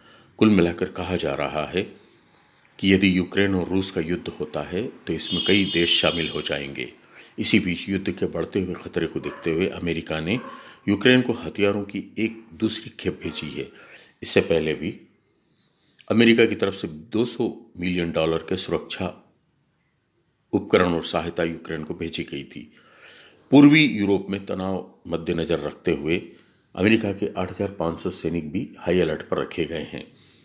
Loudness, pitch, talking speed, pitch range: -23 LUFS, 95 Hz, 160 wpm, 85-105 Hz